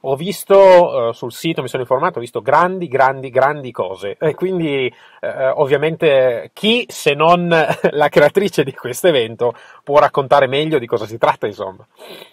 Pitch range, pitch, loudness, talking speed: 135-180 Hz, 150 Hz, -15 LUFS, 155 wpm